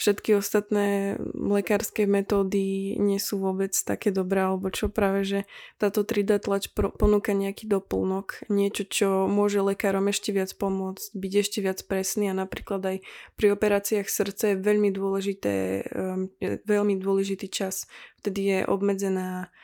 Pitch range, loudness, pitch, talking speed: 195-205 Hz, -26 LUFS, 200 Hz, 135 wpm